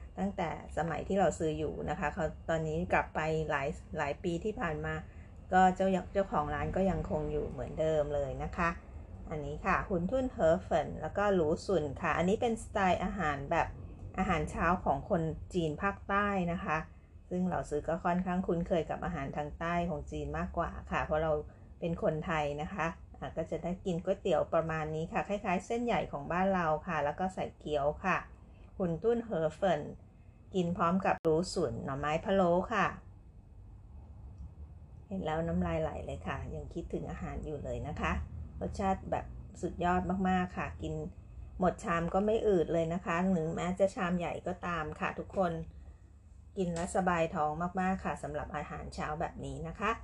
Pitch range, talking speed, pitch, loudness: 150-185 Hz, 530 characters per minute, 165 Hz, -34 LUFS